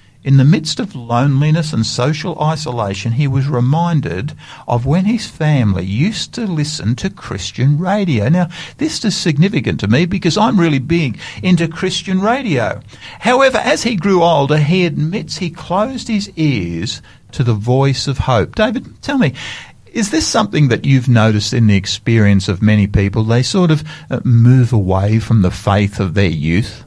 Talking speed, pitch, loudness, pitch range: 170 wpm, 145 Hz, -15 LUFS, 115-175 Hz